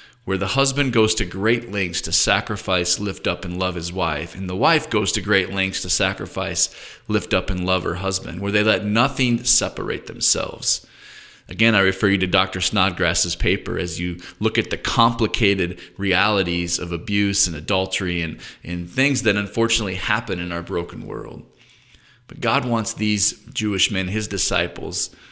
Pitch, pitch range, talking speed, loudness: 95 Hz, 90-110 Hz, 175 wpm, -20 LUFS